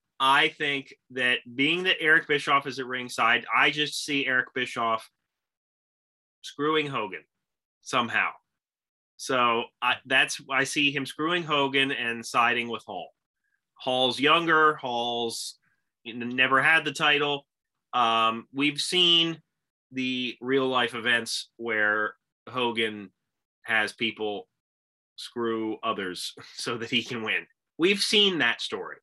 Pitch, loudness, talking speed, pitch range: 130 Hz, -25 LUFS, 120 wpm, 115-145 Hz